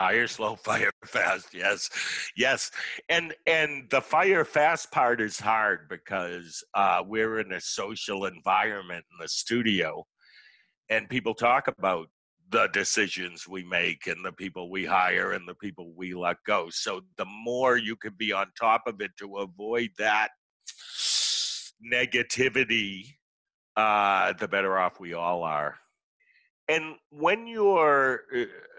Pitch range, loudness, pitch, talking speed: 95-150 Hz, -27 LUFS, 115 Hz, 140 wpm